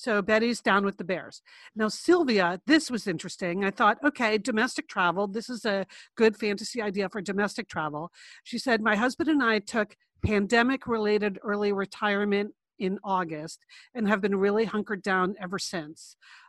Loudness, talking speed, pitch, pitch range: -27 LUFS, 165 wpm, 210 Hz, 195-230 Hz